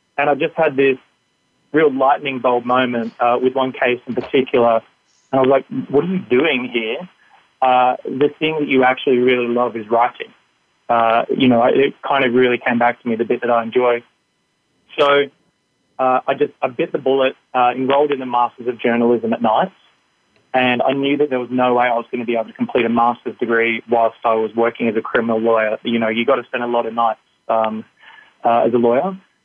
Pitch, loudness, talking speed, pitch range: 125 Hz, -17 LUFS, 220 wpm, 115-135 Hz